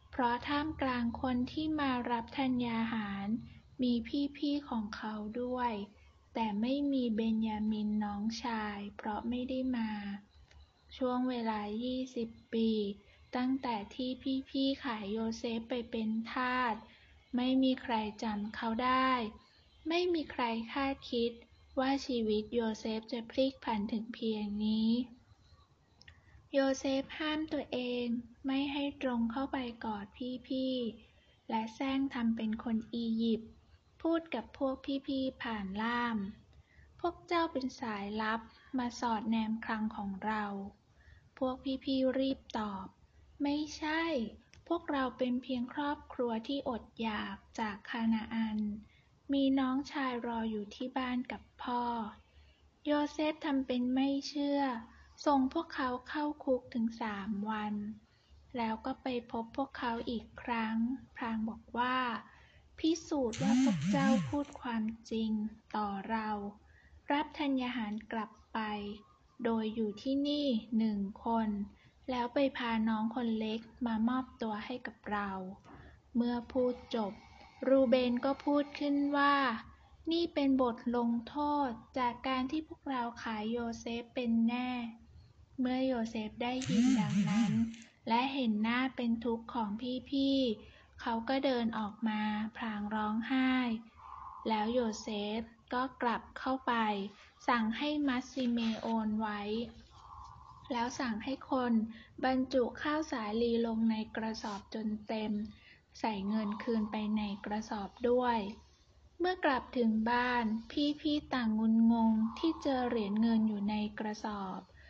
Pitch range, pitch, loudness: 220-265 Hz, 240 Hz, -35 LUFS